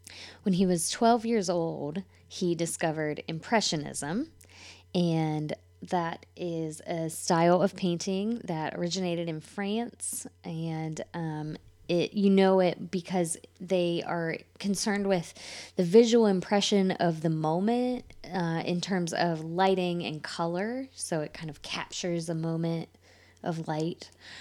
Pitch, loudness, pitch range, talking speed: 175 Hz, -29 LUFS, 160-190 Hz, 130 wpm